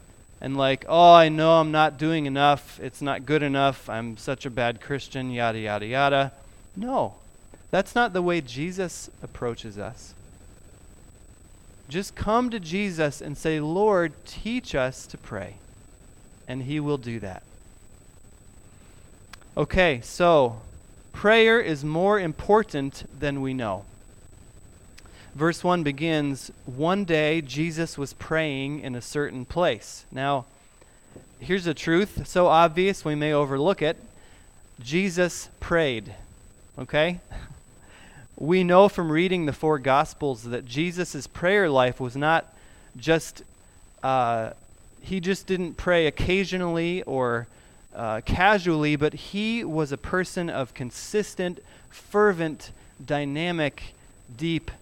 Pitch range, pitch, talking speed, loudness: 120-170 Hz, 145 Hz, 125 wpm, -24 LUFS